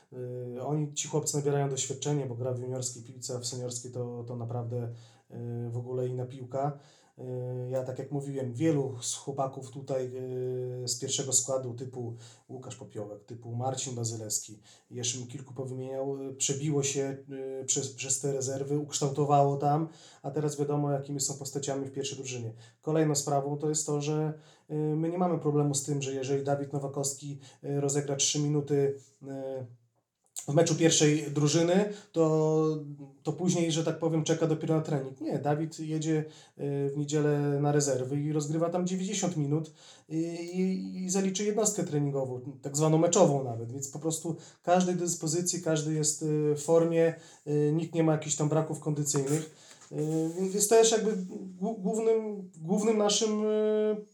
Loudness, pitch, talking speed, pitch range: -30 LUFS, 145 Hz, 150 wpm, 135-160 Hz